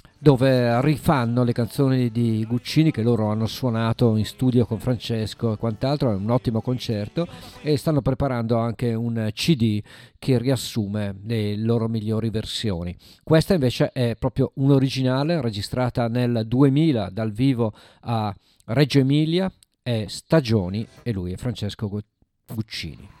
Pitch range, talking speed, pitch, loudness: 110-135 Hz, 135 wpm, 120 Hz, -23 LUFS